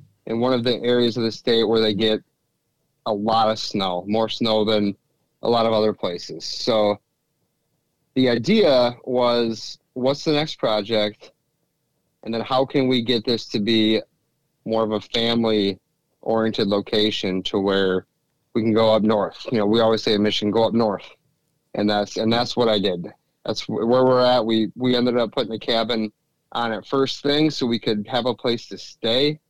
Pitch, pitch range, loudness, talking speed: 115 Hz, 110-125 Hz, -21 LUFS, 185 wpm